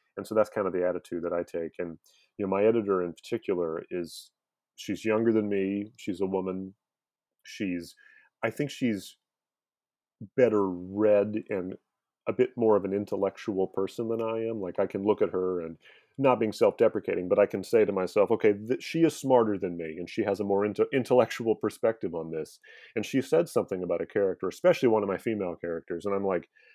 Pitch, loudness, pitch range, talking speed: 100 Hz, -28 LUFS, 90-115 Hz, 205 wpm